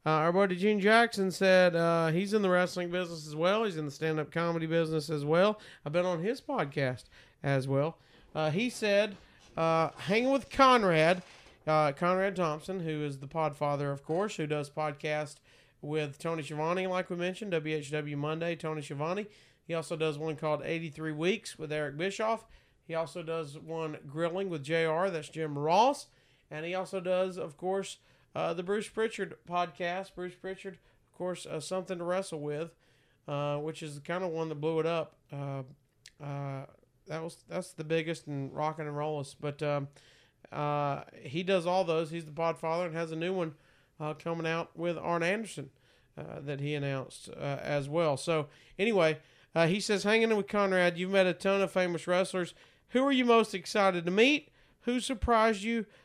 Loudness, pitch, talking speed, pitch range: -31 LUFS, 165 Hz, 190 wpm, 150-185 Hz